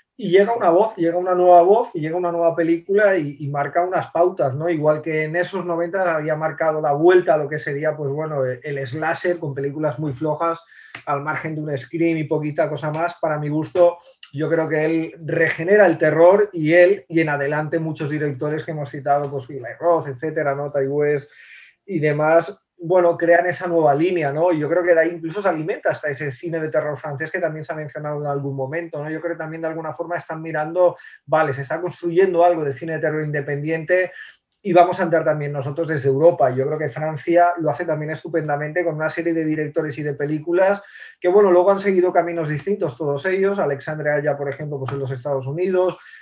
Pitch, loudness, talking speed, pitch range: 160 Hz, -20 LUFS, 220 wpm, 150-175 Hz